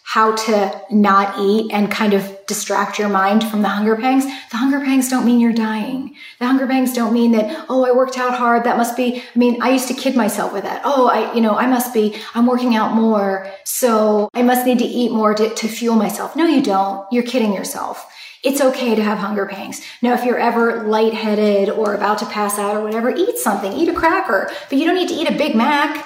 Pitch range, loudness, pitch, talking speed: 210-255 Hz, -17 LUFS, 230 Hz, 240 wpm